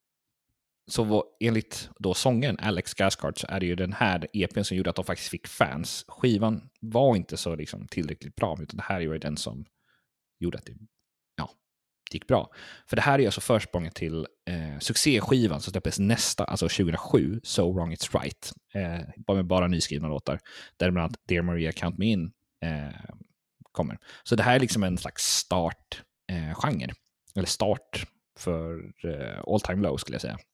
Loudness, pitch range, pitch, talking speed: -28 LUFS, 85-110 Hz, 95 Hz, 180 wpm